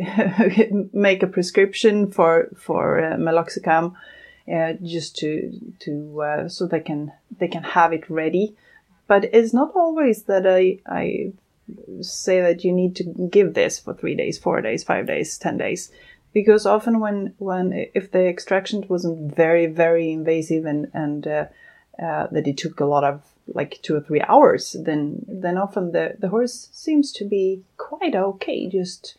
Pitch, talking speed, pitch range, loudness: 185 Hz, 165 wpm, 165-205 Hz, -21 LUFS